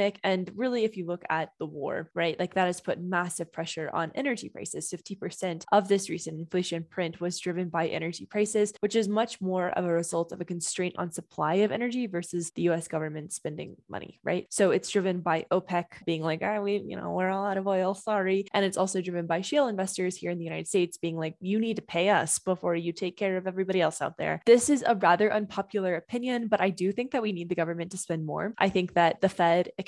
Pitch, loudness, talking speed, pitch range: 185 Hz, -29 LUFS, 235 wpm, 170-200 Hz